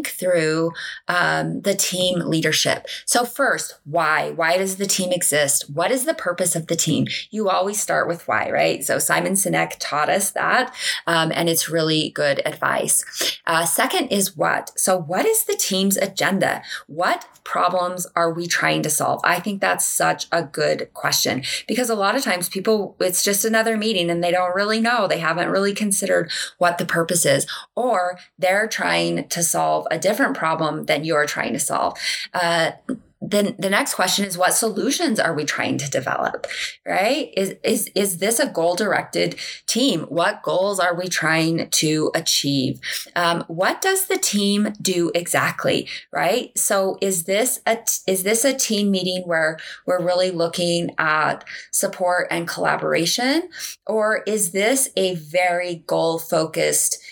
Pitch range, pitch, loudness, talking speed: 170-210 Hz, 185 Hz, -20 LUFS, 165 wpm